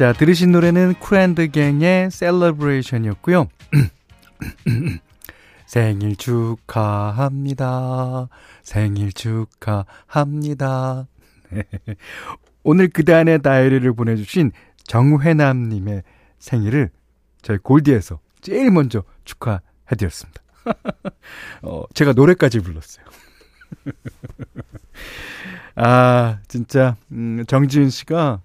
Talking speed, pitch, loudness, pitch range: 200 characters per minute, 125 Hz, -17 LUFS, 105-150 Hz